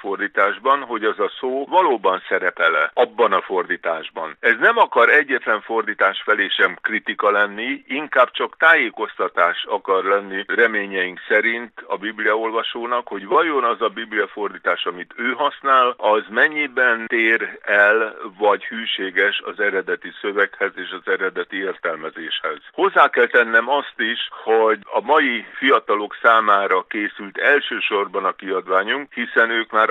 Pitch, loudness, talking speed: 130 Hz, -19 LUFS, 135 wpm